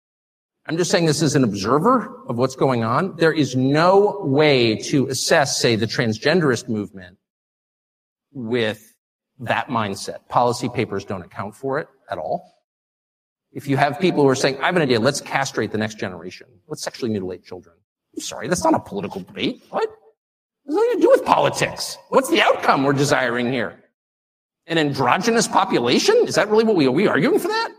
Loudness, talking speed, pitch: -19 LUFS, 185 wpm, 140 Hz